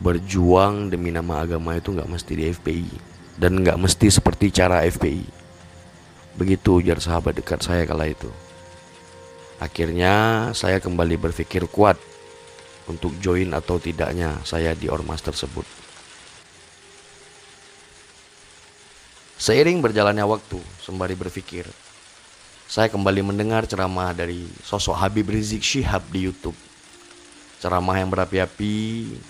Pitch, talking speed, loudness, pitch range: 90 Hz, 110 wpm, -21 LUFS, 85-100 Hz